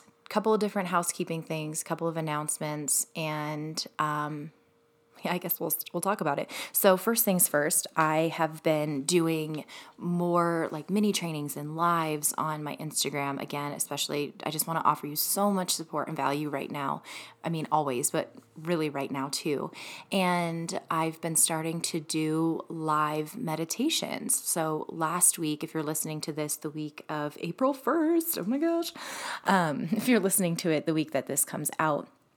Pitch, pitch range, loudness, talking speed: 160 Hz, 150-175 Hz, -29 LUFS, 175 wpm